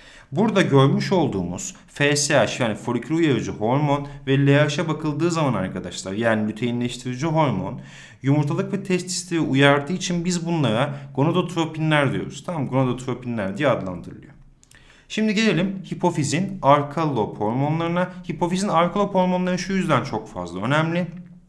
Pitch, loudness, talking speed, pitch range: 150 Hz, -22 LUFS, 120 wpm, 135-180 Hz